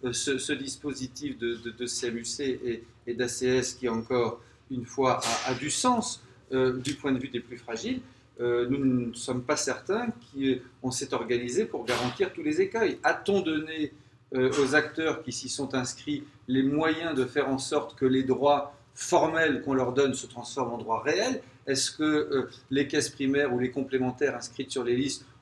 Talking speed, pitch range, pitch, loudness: 190 wpm, 125-145 Hz, 130 Hz, -29 LUFS